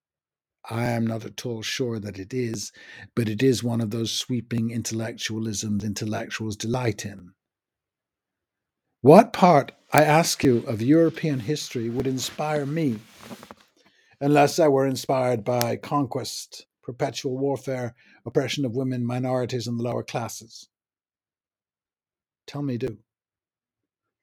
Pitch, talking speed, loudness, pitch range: 120 Hz, 125 wpm, -24 LUFS, 115-135 Hz